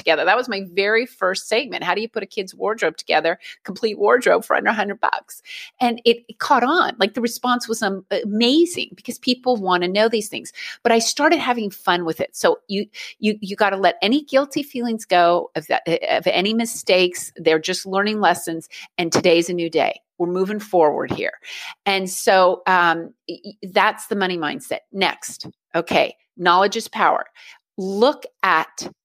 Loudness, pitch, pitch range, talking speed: -20 LUFS, 205 Hz, 185-240 Hz, 185 wpm